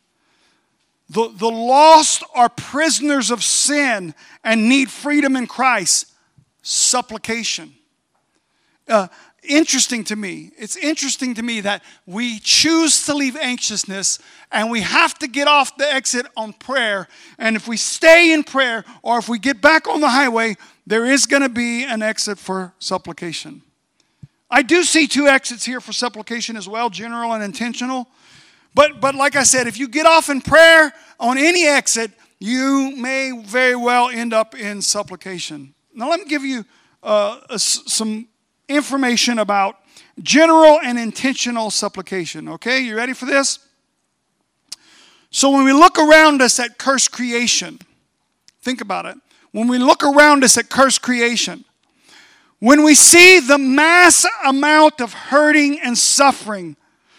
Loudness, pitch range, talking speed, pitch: -14 LUFS, 225-285 Hz, 150 wpm, 250 Hz